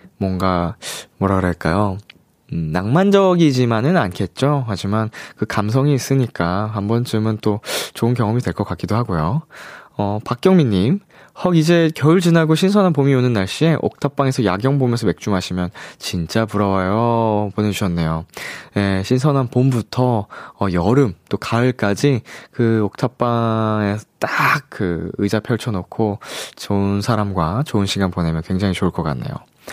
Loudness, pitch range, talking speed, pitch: -18 LUFS, 100-130 Hz, 300 characters per minute, 110 Hz